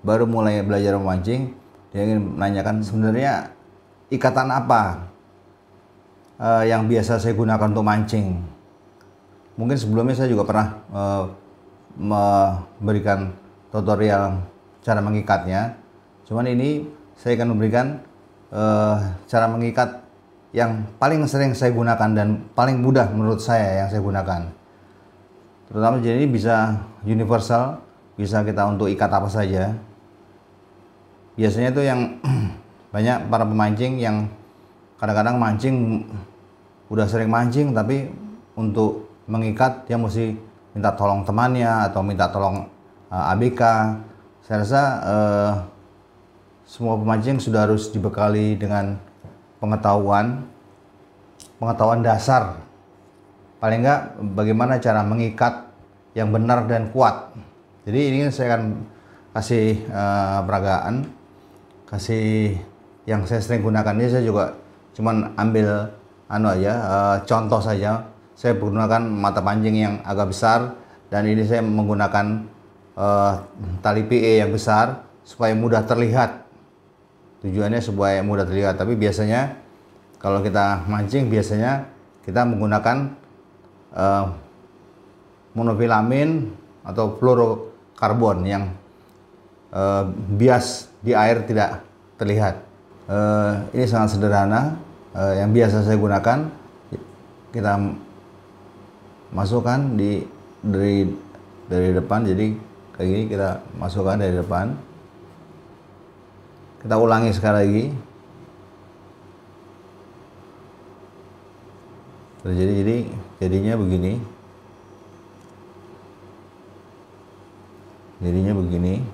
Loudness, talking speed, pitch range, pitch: -21 LUFS, 100 wpm, 100-115 Hz, 105 Hz